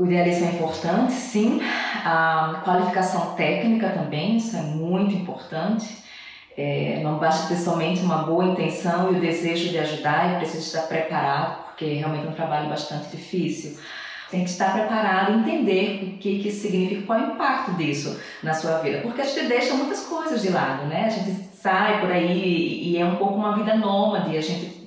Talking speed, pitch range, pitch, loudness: 190 wpm, 160-205 Hz, 180 Hz, -23 LUFS